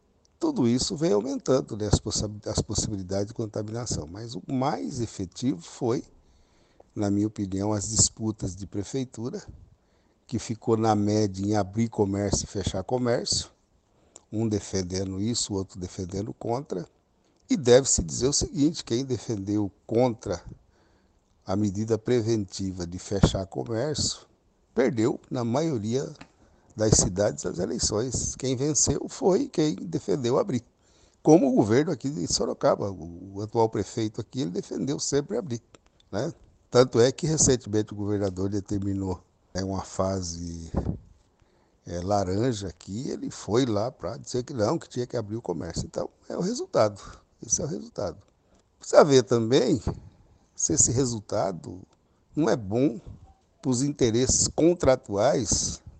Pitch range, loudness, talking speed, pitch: 95-120 Hz, -26 LUFS, 140 wpm, 105 Hz